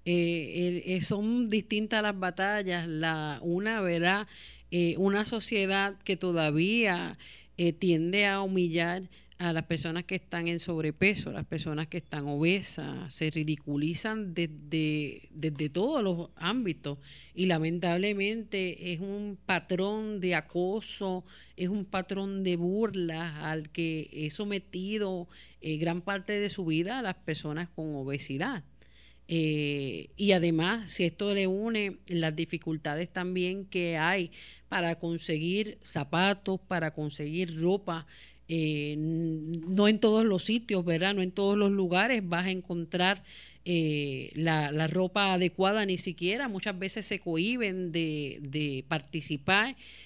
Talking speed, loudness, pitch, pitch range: 135 wpm, -30 LUFS, 175 Hz, 160-195 Hz